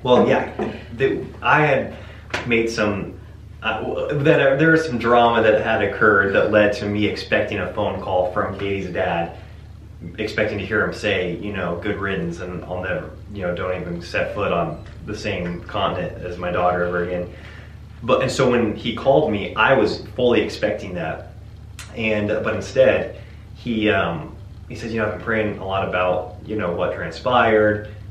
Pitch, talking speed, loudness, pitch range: 100 Hz, 175 wpm, -20 LUFS, 90-110 Hz